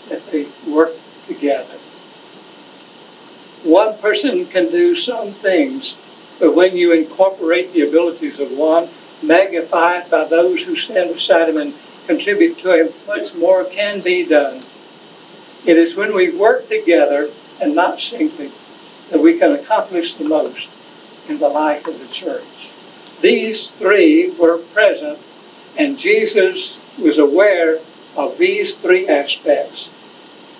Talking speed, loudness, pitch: 130 wpm, -15 LUFS, 185 Hz